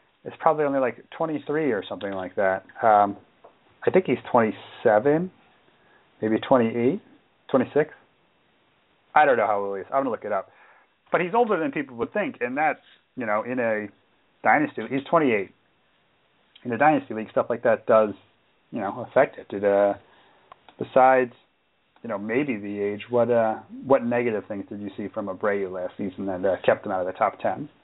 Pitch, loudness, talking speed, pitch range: 110 Hz, -24 LUFS, 185 wpm, 100-135 Hz